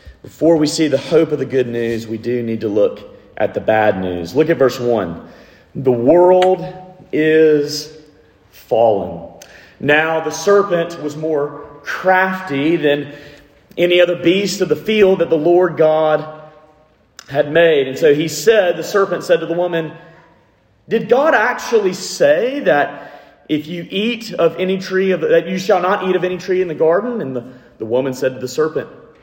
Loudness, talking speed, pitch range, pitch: -15 LUFS, 175 wpm, 145-180 Hz, 160 Hz